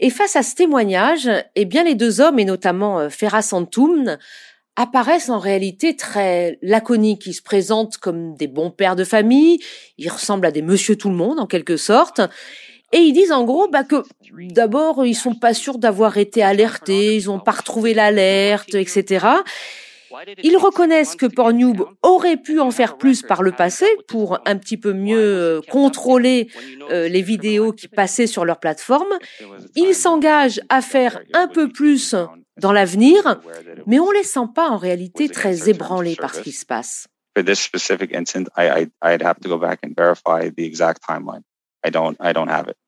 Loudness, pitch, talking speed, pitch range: -17 LUFS, 220 Hz, 155 wpm, 195-280 Hz